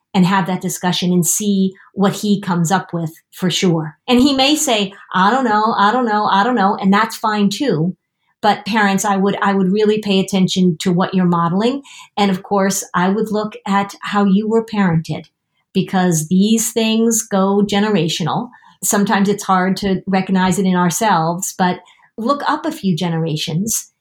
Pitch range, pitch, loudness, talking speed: 180-210 Hz, 195 Hz, -16 LUFS, 180 wpm